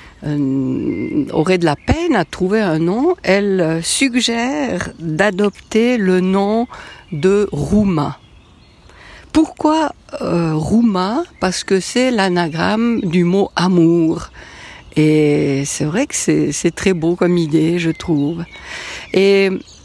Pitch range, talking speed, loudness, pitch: 165-220 Hz, 115 wpm, -16 LUFS, 185 Hz